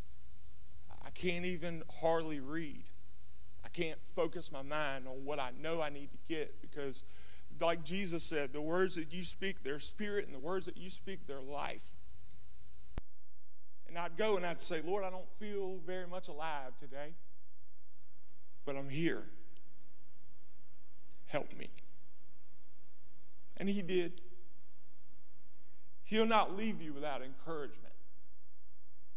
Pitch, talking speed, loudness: 135 Hz, 130 wpm, -40 LUFS